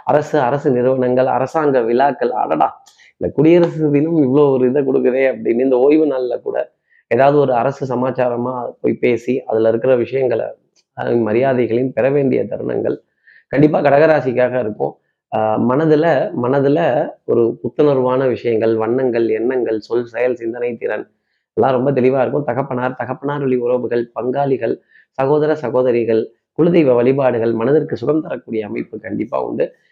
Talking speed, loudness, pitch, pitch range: 130 wpm, -16 LUFS, 130 Hz, 120-145 Hz